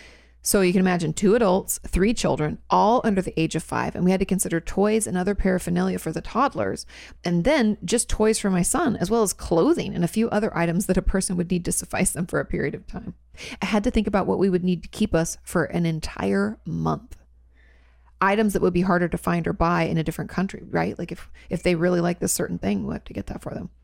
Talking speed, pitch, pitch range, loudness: 255 wpm, 180 Hz, 165-200 Hz, -23 LUFS